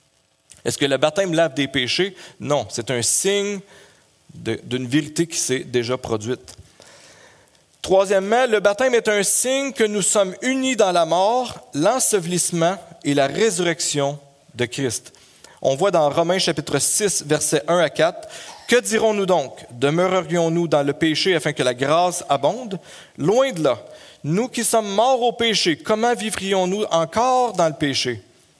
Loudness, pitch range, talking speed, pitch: -19 LUFS, 140-210 Hz, 155 wpm, 170 Hz